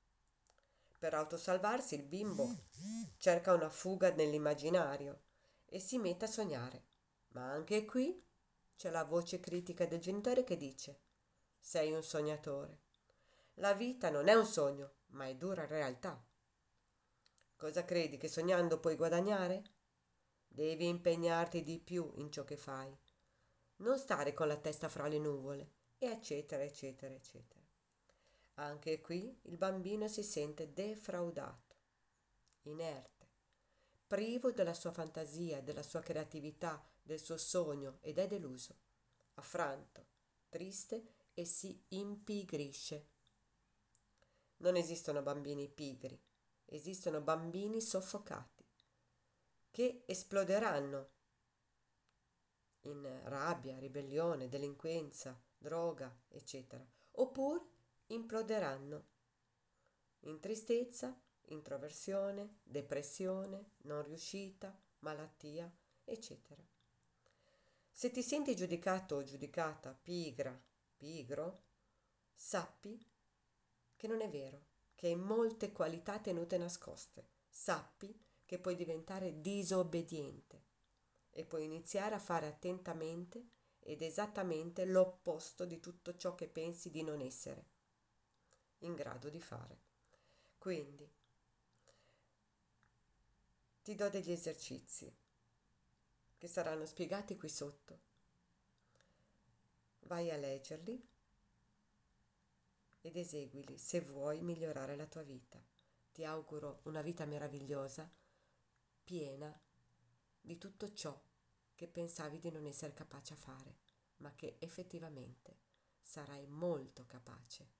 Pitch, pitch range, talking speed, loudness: 160 Hz, 145-185 Hz, 105 wpm, -39 LUFS